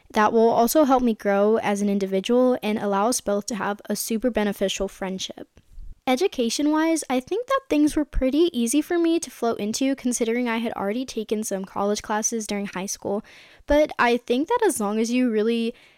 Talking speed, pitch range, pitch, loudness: 200 wpm, 205-265 Hz, 230 Hz, -23 LUFS